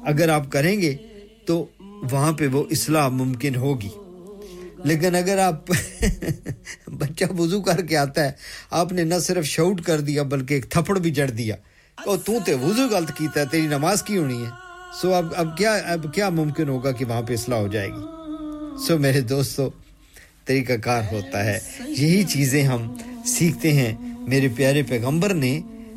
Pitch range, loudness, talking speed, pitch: 135-185 Hz, -22 LUFS, 175 wpm, 155 Hz